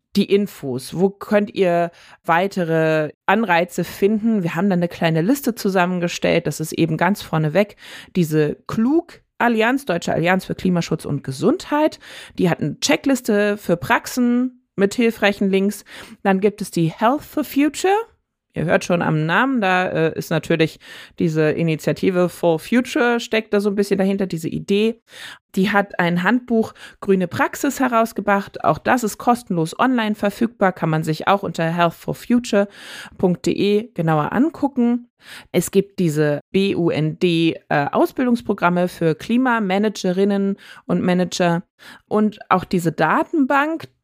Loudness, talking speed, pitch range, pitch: -19 LUFS, 135 wpm, 170-230 Hz, 195 Hz